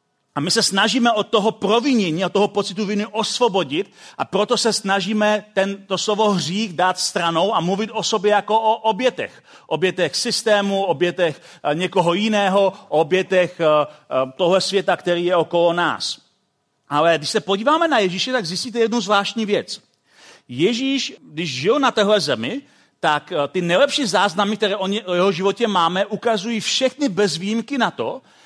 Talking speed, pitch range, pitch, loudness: 160 wpm, 180-220 Hz, 200 Hz, -19 LUFS